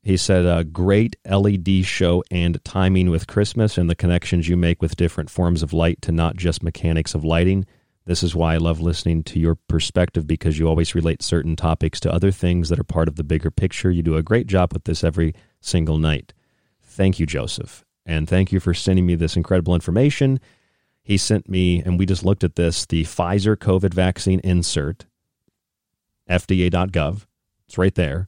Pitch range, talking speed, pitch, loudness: 80-95 Hz, 195 wpm, 90 Hz, -20 LUFS